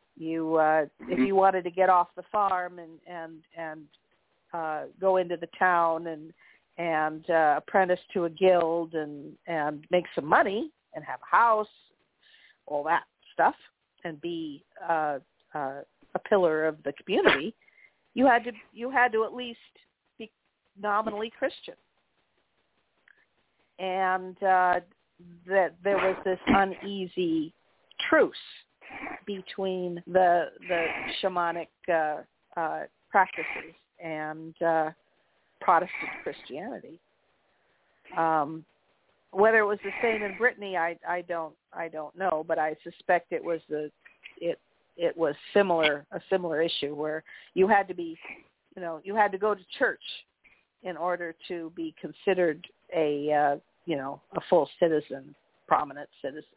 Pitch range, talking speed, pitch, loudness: 160-195 Hz, 140 wpm, 175 Hz, -28 LUFS